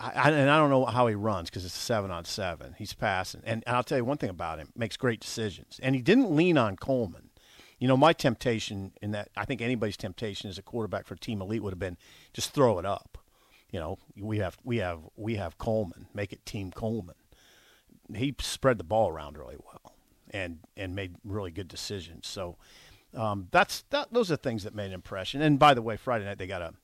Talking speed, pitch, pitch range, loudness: 230 wpm, 110 Hz, 95-125 Hz, -29 LUFS